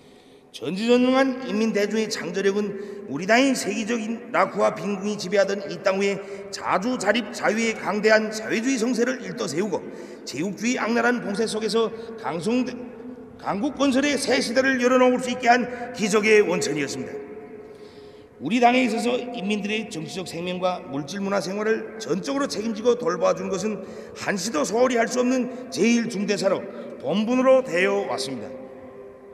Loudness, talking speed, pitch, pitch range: -23 LUFS, 335 characters per minute, 220 Hz, 200-245 Hz